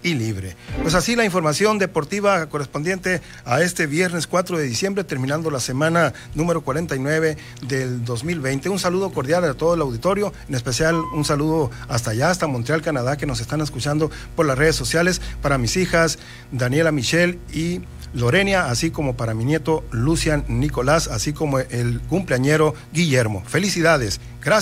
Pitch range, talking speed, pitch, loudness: 130-170 Hz, 160 wpm, 155 Hz, -20 LUFS